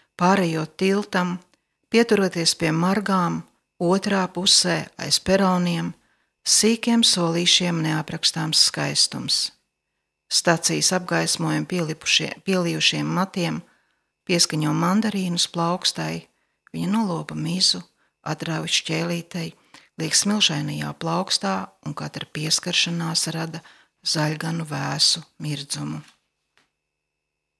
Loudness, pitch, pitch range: -21 LUFS, 165 Hz, 150-180 Hz